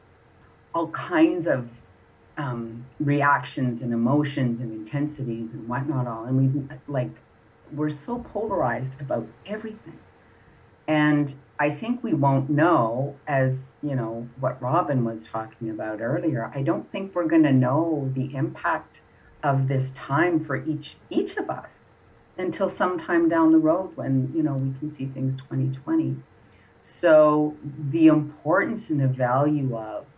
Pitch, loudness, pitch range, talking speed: 140 Hz, -24 LUFS, 120-155 Hz, 145 wpm